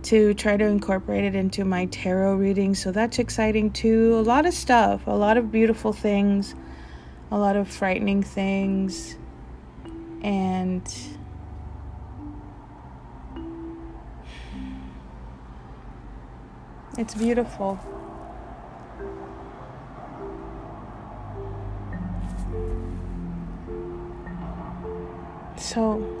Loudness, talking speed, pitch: -24 LUFS, 70 wpm, 100 Hz